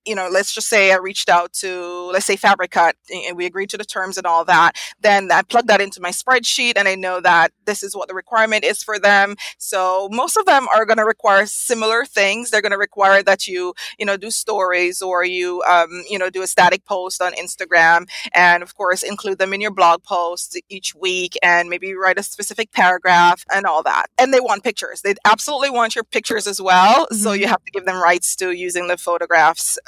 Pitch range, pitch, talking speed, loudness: 180-215 Hz, 195 Hz, 225 wpm, -16 LUFS